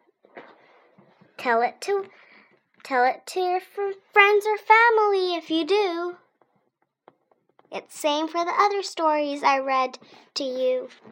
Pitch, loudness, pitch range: 370 Hz, -22 LUFS, 310-405 Hz